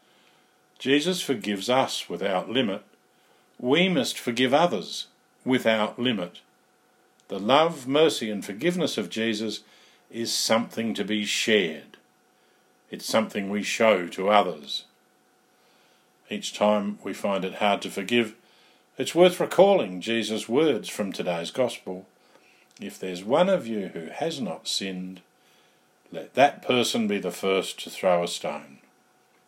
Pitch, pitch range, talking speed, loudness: 110 Hz, 100-135 Hz, 130 wpm, -25 LUFS